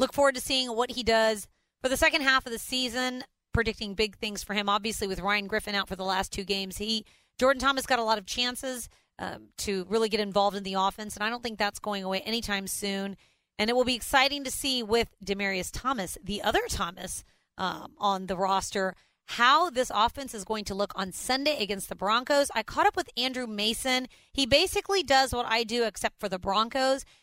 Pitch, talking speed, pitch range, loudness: 225 Hz, 220 wpm, 200-255 Hz, -28 LUFS